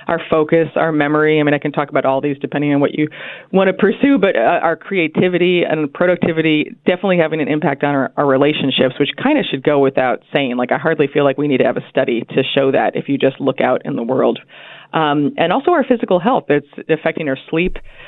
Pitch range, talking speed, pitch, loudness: 145-175 Hz, 240 wpm, 155 Hz, -16 LUFS